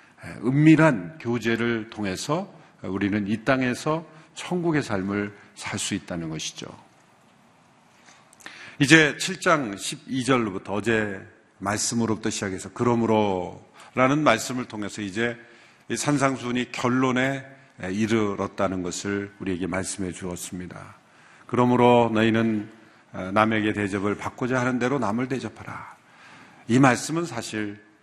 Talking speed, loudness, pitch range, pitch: 260 characters per minute, -24 LUFS, 100-130 Hz, 115 Hz